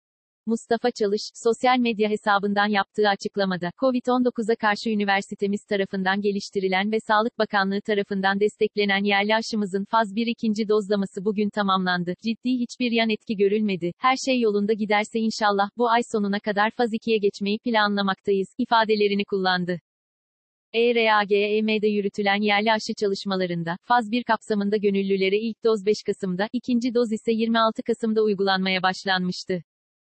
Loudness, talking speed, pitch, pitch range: -23 LUFS, 130 wpm, 210 Hz, 200-225 Hz